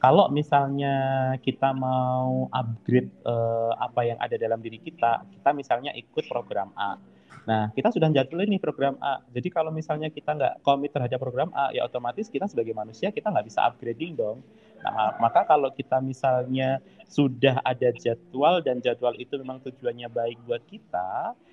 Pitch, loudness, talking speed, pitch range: 130 Hz, -26 LUFS, 165 wpm, 120-145 Hz